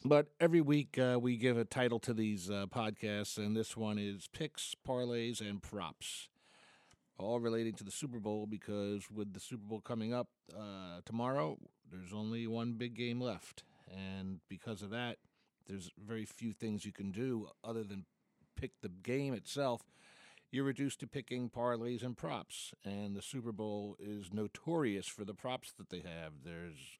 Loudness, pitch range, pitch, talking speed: -40 LUFS, 100-125 Hz, 110 Hz, 175 wpm